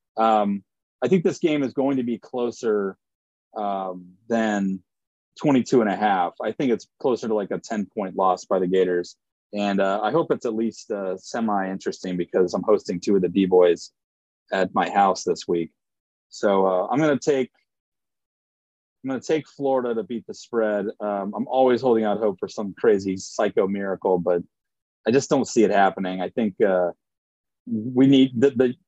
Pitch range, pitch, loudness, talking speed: 90-120 Hz, 100 Hz, -23 LUFS, 190 wpm